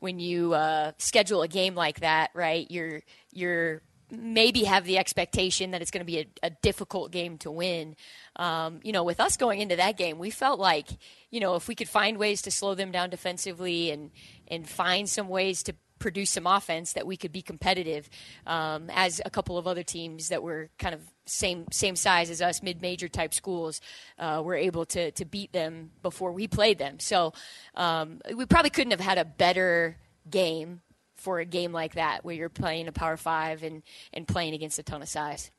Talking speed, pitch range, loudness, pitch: 205 wpm, 160-190 Hz, -28 LUFS, 175 Hz